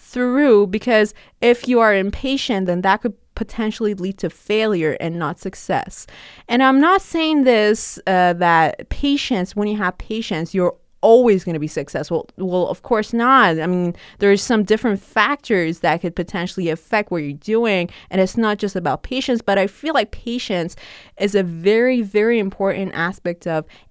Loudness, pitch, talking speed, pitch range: -18 LUFS, 200 Hz, 175 wpm, 180-235 Hz